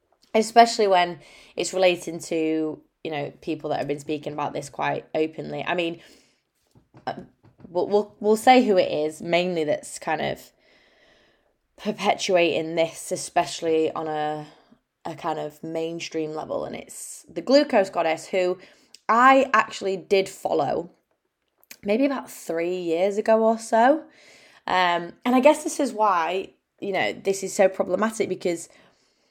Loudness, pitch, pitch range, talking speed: -23 LUFS, 185 Hz, 160-215 Hz, 145 wpm